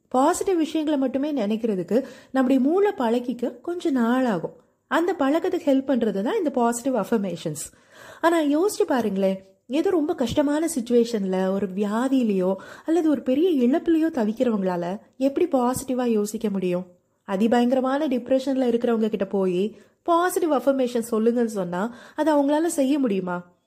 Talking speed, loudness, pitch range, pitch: 120 wpm, -23 LUFS, 210-295 Hz, 255 Hz